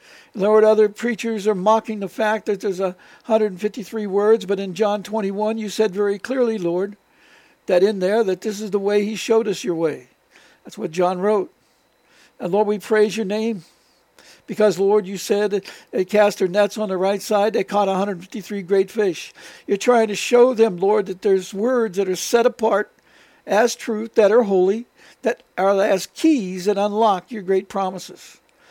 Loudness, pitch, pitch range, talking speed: -20 LUFS, 210 Hz, 195-220 Hz, 185 wpm